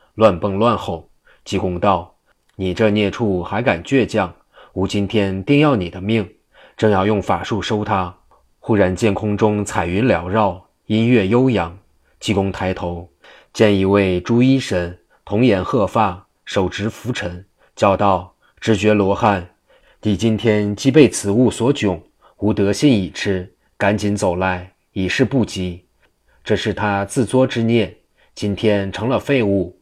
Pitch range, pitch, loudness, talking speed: 95-110 Hz, 100 Hz, -18 LUFS, 205 characters per minute